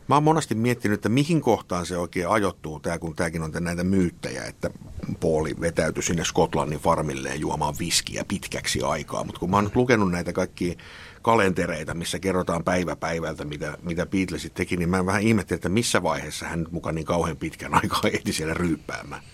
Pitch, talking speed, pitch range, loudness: 90 Hz, 185 wpm, 85-100 Hz, -25 LUFS